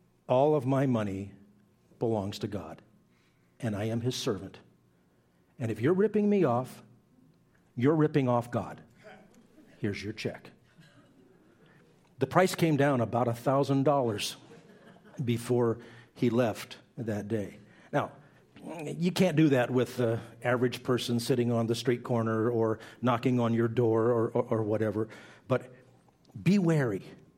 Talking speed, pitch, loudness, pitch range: 135 wpm, 120 Hz, -29 LUFS, 110-135 Hz